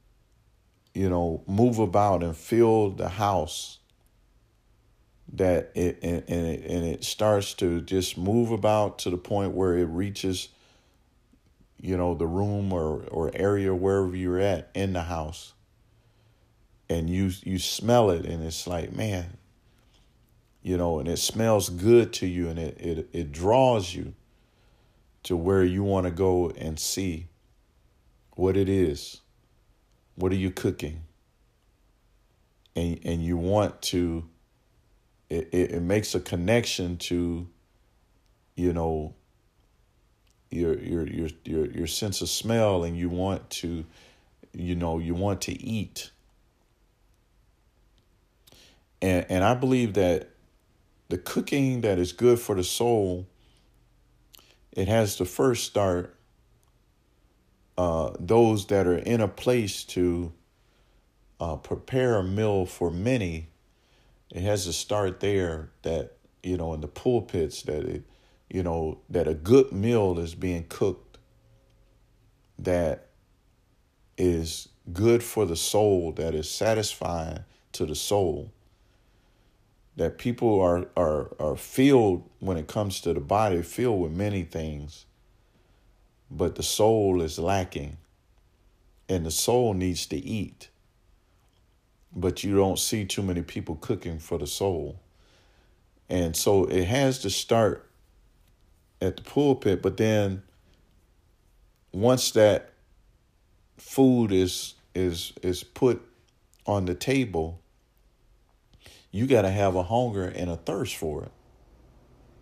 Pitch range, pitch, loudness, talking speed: 85-110 Hz, 95 Hz, -26 LUFS, 130 wpm